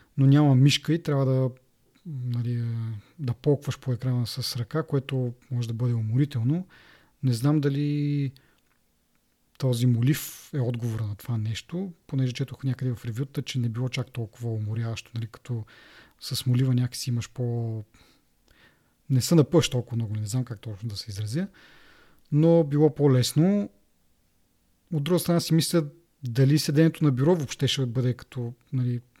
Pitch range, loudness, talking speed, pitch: 115-145 Hz, -26 LUFS, 155 wpm, 125 Hz